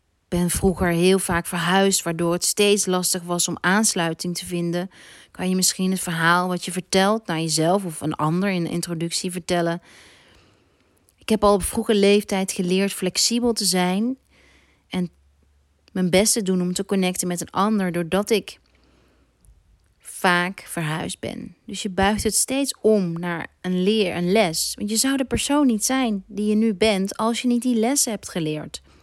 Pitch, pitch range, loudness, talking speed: 185 Hz, 170-210 Hz, -21 LUFS, 180 wpm